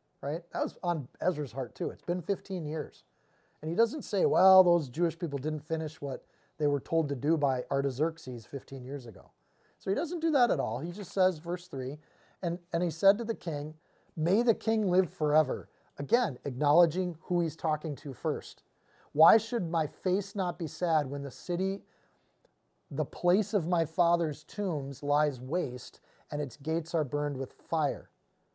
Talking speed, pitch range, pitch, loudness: 185 wpm, 145-185 Hz, 165 Hz, -30 LUFS